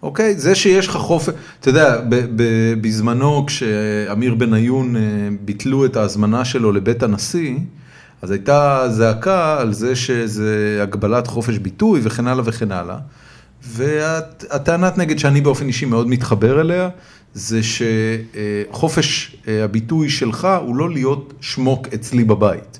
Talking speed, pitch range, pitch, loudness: 125 wpm, 110-145 Hz, 125 Hz, -17 LUFS